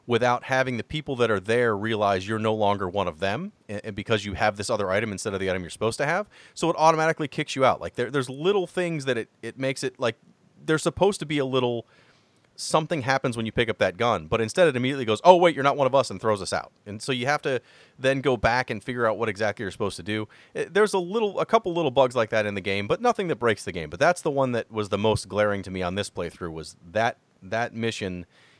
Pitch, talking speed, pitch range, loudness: 120 Hz, 270 wpm, 105-145 Hz, -25 LUFS